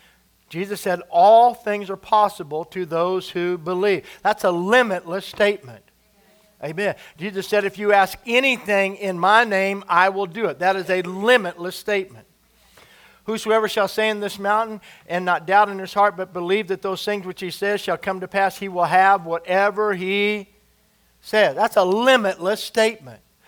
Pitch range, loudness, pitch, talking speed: 185-210 Hz, -20 LUFS, 195 Hz, 170 wpm